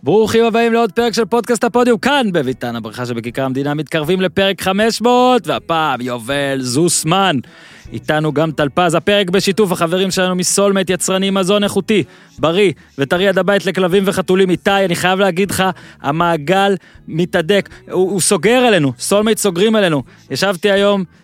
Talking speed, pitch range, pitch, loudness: 145 wpm, 160-205 Hz, 190 Hz, -15 LUFS